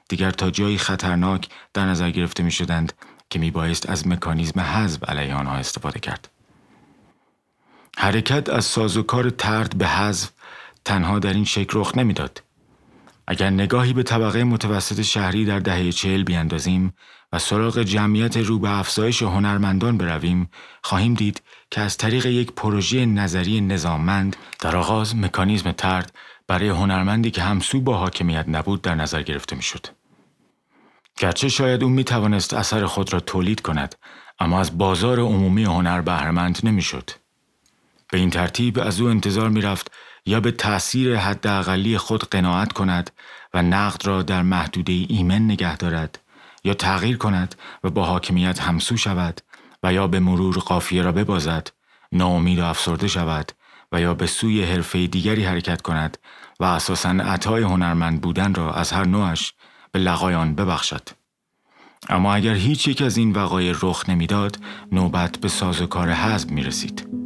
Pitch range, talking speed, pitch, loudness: 90-105 Hz, 155 wpm, 95 Hz, -21 LUFS